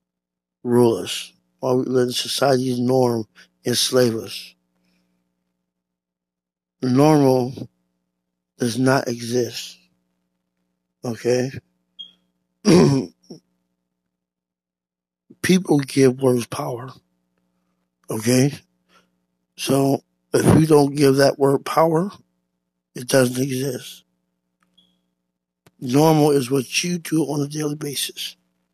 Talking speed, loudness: 80 wpm, -19 LUFS